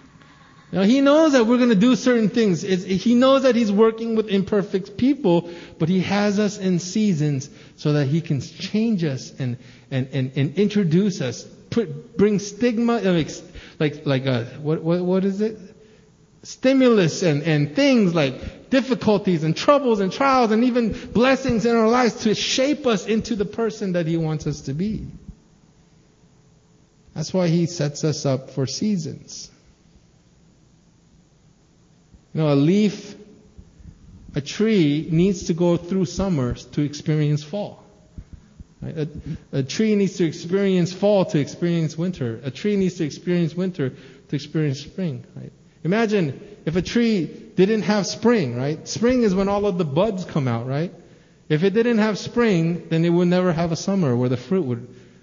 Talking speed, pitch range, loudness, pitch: 160 wpm, 155-215 Hz, -21 LUFS, 180 Hz